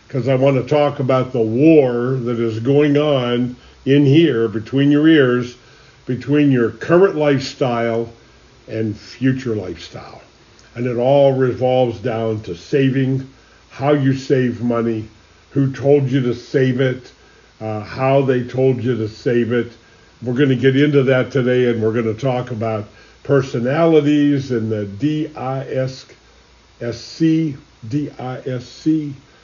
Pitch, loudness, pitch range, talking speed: 130 Hz, -17 LUFS, 115-140 Hz, 150 wpm